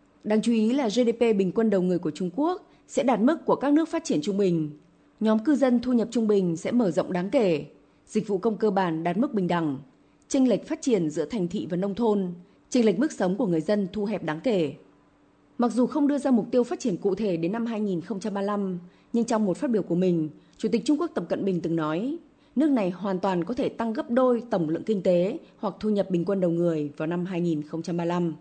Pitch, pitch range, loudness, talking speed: 205 Hz, 175-245 Hz, -26 LUFS, 245 wpm